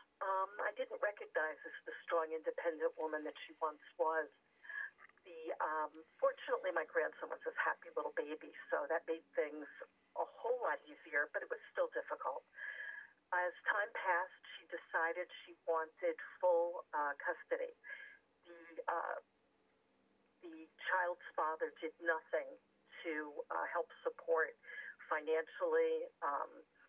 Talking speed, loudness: 130 wpm, -41 LUFS